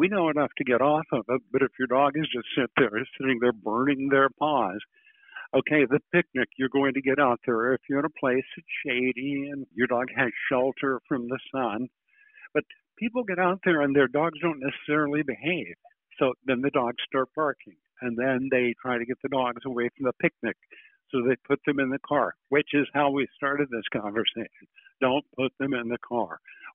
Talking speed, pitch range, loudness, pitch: 210 wpm, 130-150 Hz, -26 LUFS, 135 Hz